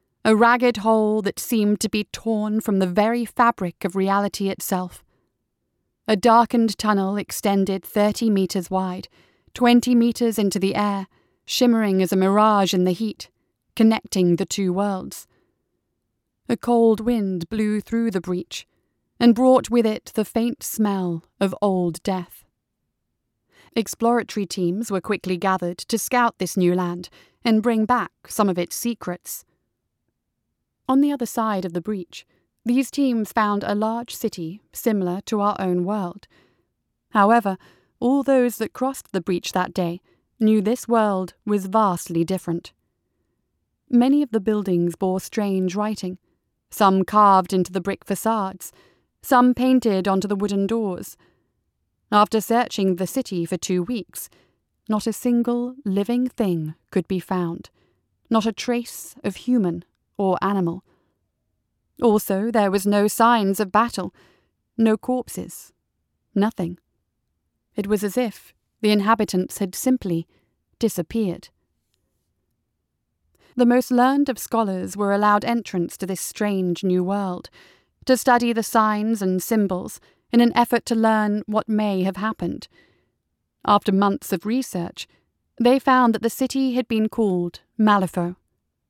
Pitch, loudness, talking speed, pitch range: 205 Hz, -21 LUFS, 140 wpm, 185-230 Hz